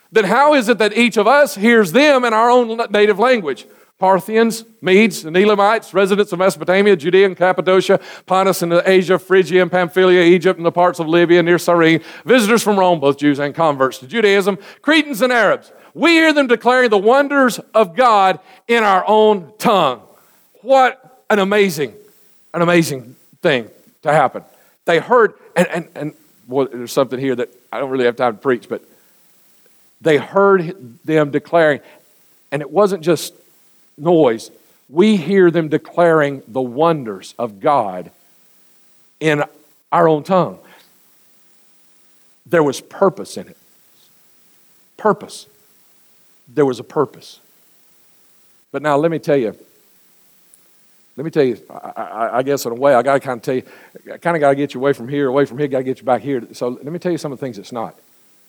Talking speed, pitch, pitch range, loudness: 175 wpm, 180 Hz, 145-210 Hz, -15 LUFS